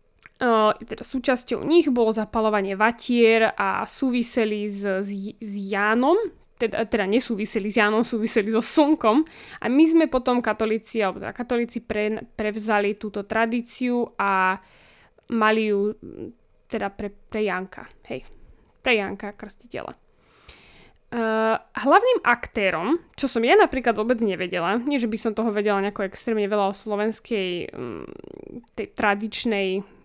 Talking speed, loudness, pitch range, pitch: 130 wpm, -23 LUFS, 210-240 Hz, 220 Hz